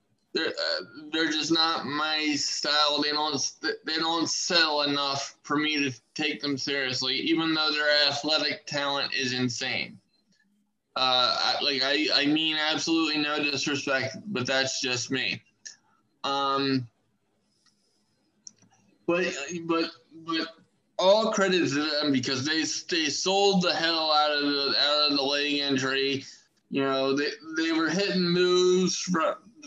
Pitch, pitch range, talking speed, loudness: 150 Hz, 140-165 Hz, 140 wpm, -25 LUFS